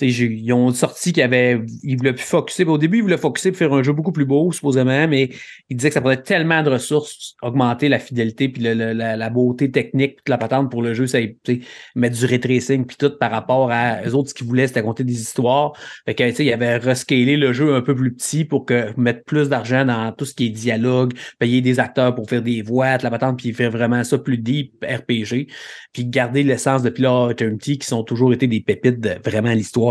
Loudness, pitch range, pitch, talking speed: -18 LUFS, 120-140 Hz, 125 Hz, 240 wpm